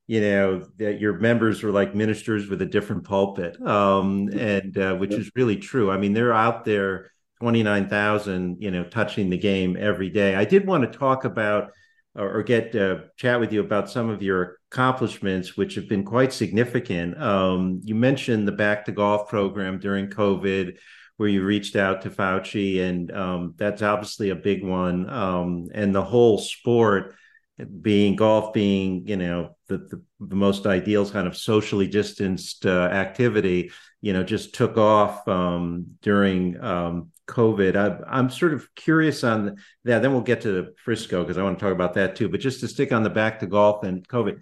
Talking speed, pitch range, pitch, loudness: 185 wpm, 95-110 Hz, 100 Hz, -23 LUFS